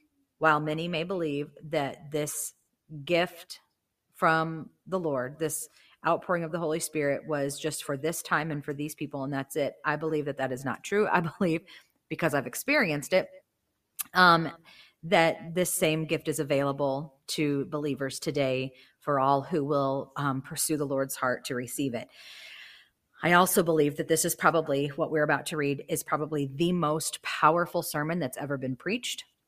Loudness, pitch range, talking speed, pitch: -28 LUFS, 140-165 Hz, 175 wpm, 155 Hz